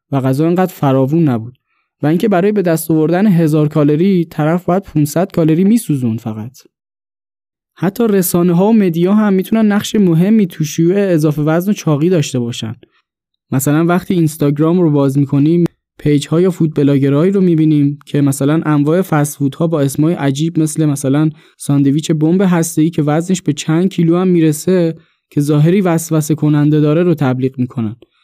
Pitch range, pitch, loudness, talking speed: 145-175 Hz, 160 Hz, -13 LUFS, 165 wpm